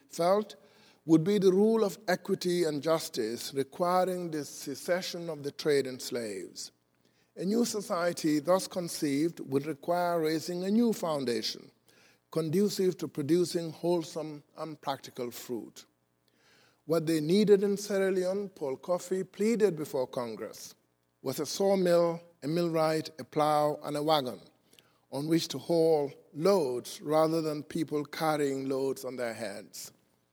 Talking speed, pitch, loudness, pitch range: 135 wpm, 160 Hz, -30 LUFS, 140-180 Hz